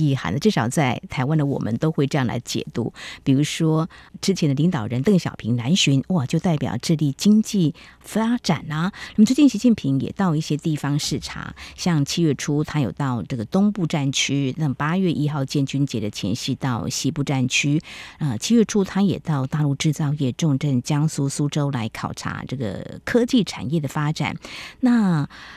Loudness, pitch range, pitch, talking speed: -22 LUFS, 135-175 Hz, 150 Hz, 280 characters per minute